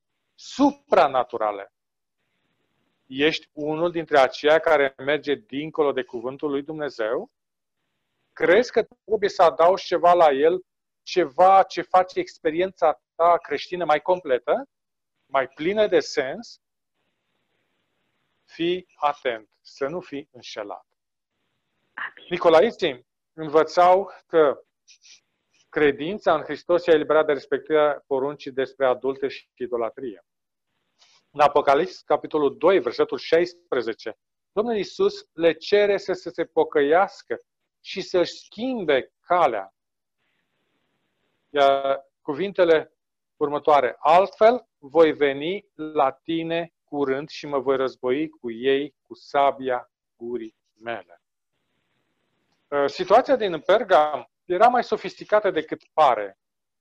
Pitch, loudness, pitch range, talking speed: 160 Hz, -22 LUFS, 140-190 Hz, 100 wpm